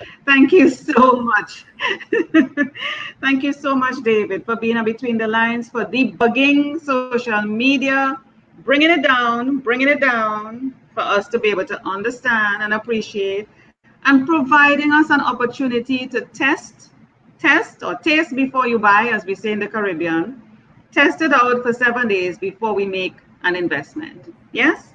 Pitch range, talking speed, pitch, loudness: 215-275 Hz, 155 wpm, 245 Hz, -17 LUFS